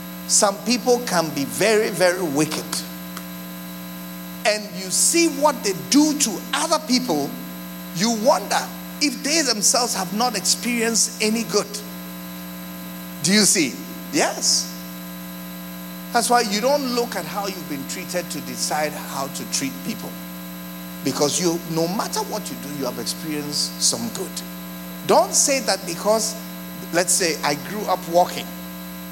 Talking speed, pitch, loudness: 140 wpm, 150 Hz, -20 LUFS